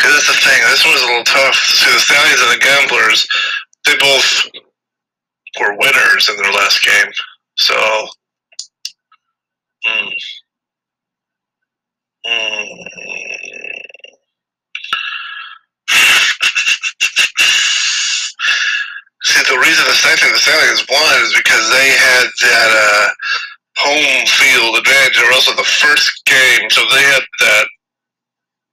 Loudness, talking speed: -9 LUFS, 115 wpm